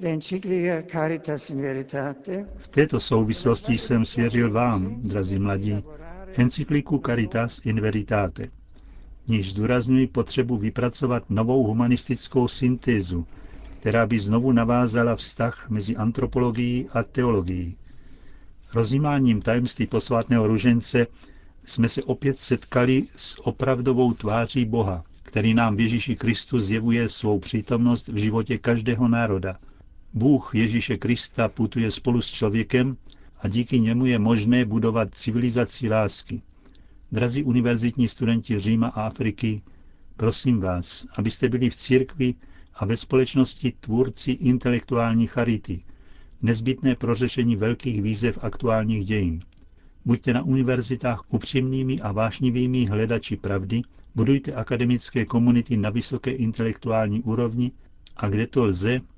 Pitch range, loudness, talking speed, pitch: 110-125 Hz, -24 LUFS, 115 wpm, 115 Hz